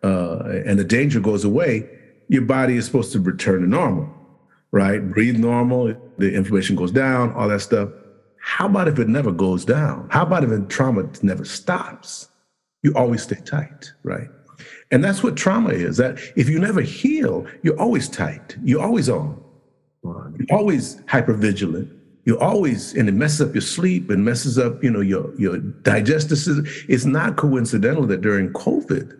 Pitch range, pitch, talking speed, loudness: 105-150 Hz, 130 Hz, 175 wpm, -20 LUFS